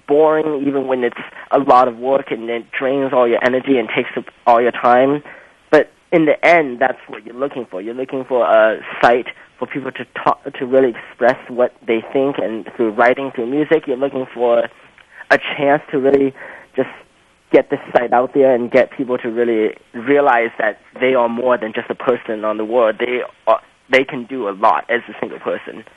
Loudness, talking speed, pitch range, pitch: -16 LUFS, 210 wpm, 120-135 Hz, 125 Hz